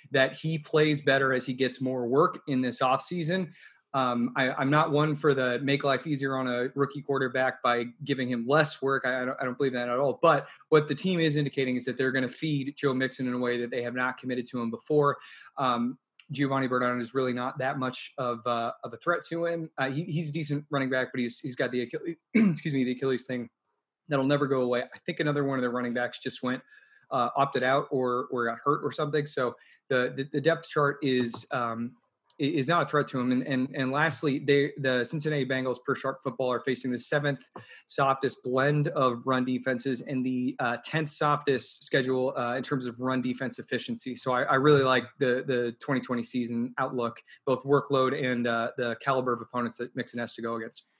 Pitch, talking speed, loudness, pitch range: 130 Hz, 225 wpm, -28 LUFS, 125-145 Hz